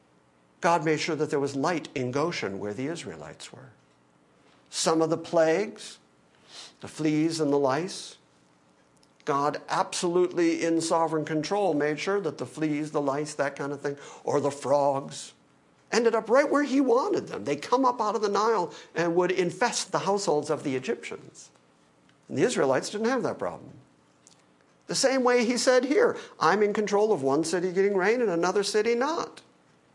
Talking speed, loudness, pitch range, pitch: 175 wpm, -26 LUFS, 130-200 Hz, 160 Hz